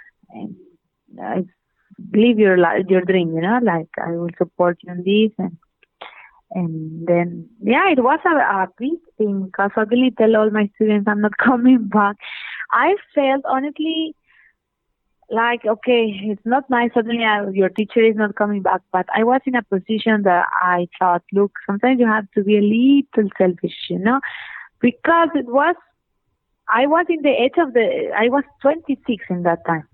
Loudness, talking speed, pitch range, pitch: -18 LUFS, 180 wpm, 190-255 Hz, 215 Hz